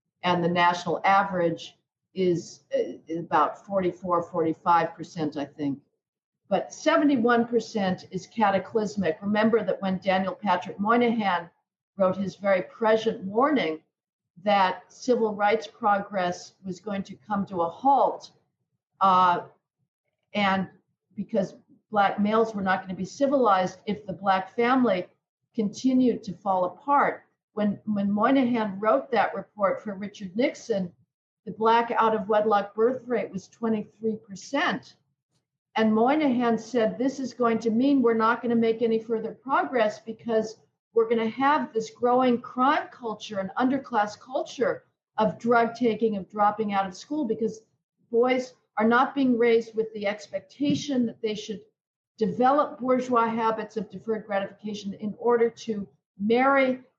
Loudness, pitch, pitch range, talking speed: -25 LUFS, 215 Hz, 190-235 Hz, 140 wpm